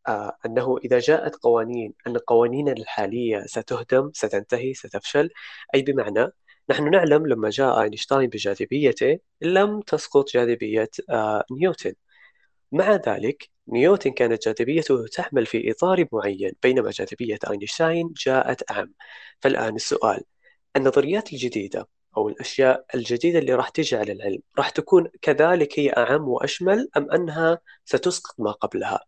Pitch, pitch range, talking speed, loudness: 135 Hz, 120-170 Hz, 125 wpm, -22 LUFS